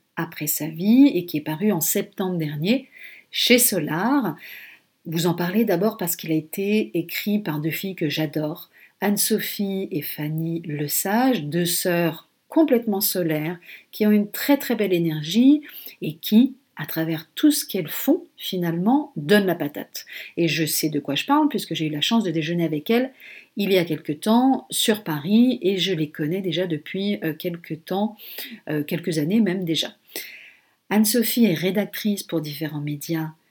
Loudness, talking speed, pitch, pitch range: -22 LUFS, 170 wpm, 185 Hz, 160-215 Hz